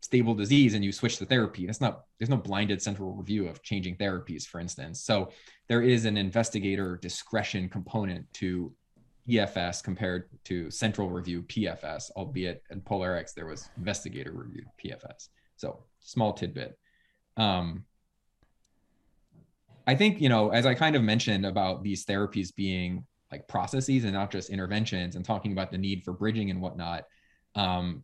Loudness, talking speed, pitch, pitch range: -29 LUFS, 160 wpm, 100 Hz, 90-110 Hz